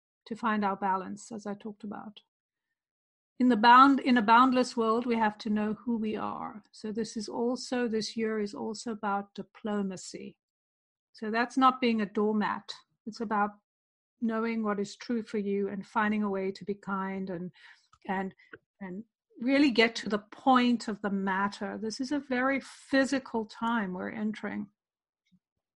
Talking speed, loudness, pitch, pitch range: 170 wpm, -29 LUFS, 220 Hz, 205-240 Hz